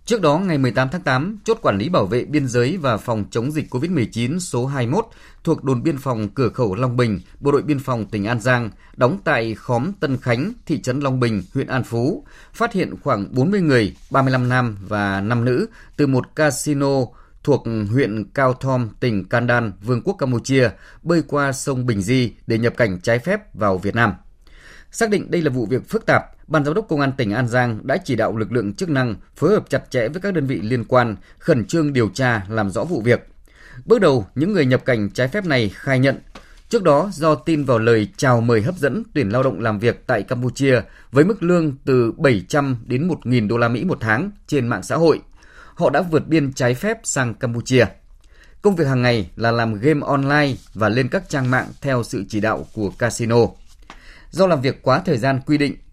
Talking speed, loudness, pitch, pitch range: 220 wpm, -19 LUFS, 125 Hz, 115-145 Hz